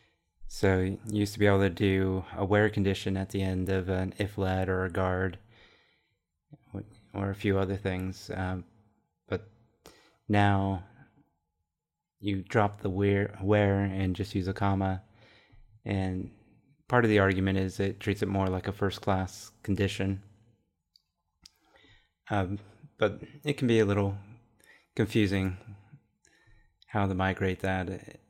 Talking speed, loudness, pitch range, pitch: 135 wpm, -30 LUFS, 95-105 Hz, 100 Hz